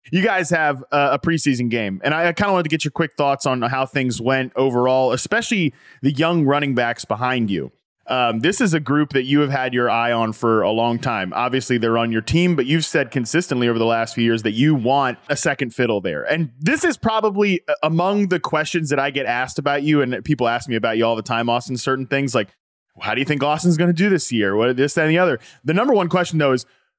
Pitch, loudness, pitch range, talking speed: 140 Hz, -19 LUFS, 120-165 Hz, 255 wpm